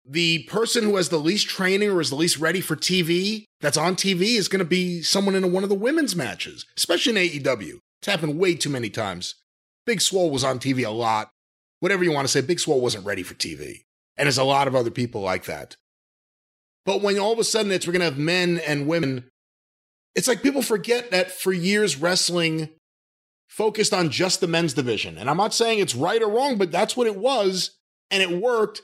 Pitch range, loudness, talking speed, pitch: 145-200 Hz, -22 LUFS, 225 wpm, 180 Hz